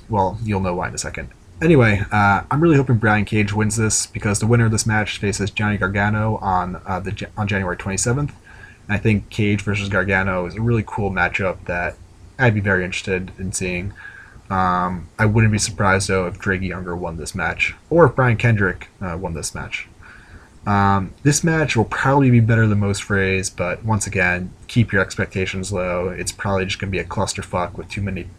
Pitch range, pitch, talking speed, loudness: 95-110 Hz, 100 Hz, 205 wpm, -19 LUFS